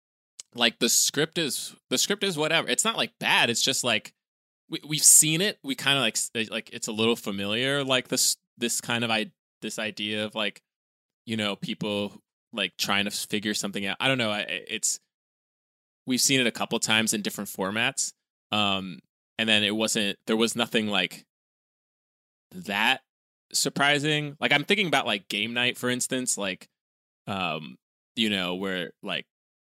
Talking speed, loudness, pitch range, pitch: 175 wpm, -25 LUFS, 105-135 Hz, 115 Hz